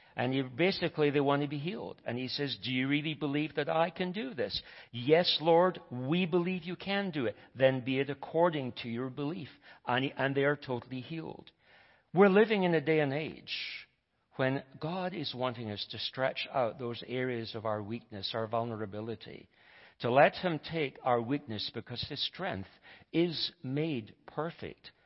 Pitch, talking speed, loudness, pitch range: 140 Hz, 175 wpm, -32 LUFS, 120-160 Hz